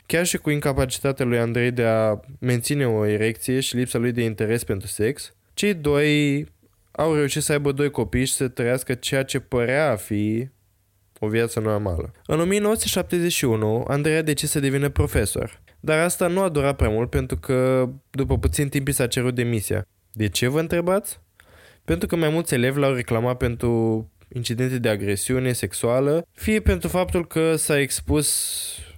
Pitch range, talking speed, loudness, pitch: 115-150 Hz, 170 wpm, -22 LUFS, 130 Hz